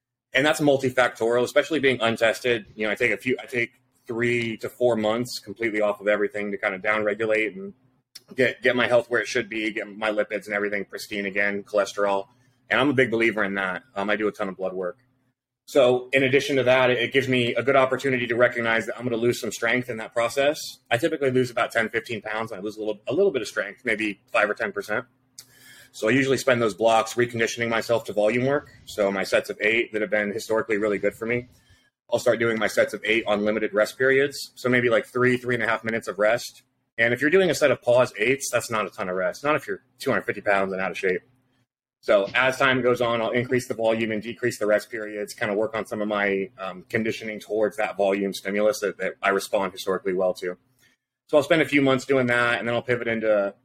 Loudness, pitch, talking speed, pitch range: -23 LUFS, 115 Hz, 245 wpm, 105-125 Hz